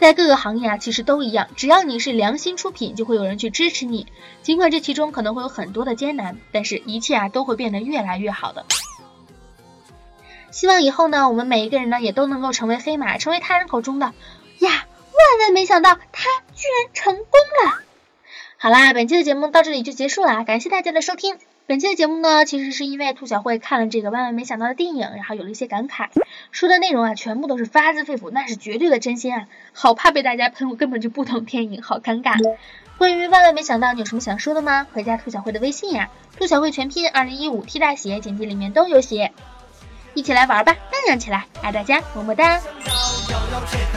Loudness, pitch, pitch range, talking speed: -18 LUFS, 265 Hz, 230-320 Hz, 340 characters per minute